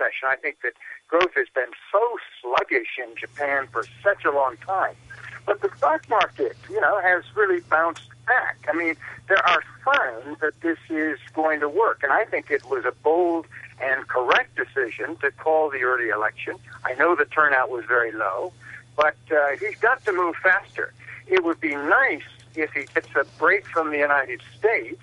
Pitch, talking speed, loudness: 160 Hz, 185 wpm, -23 LUFS